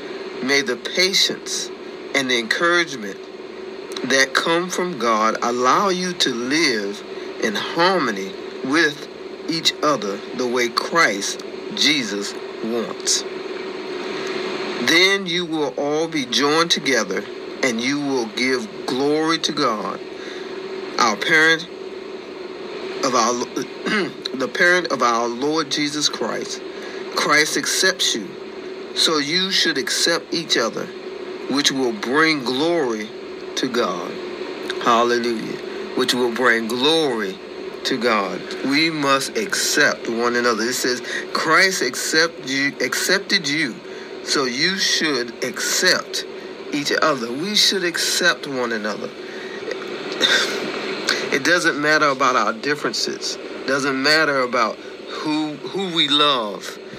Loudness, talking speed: -19 LUFS, 115 wpm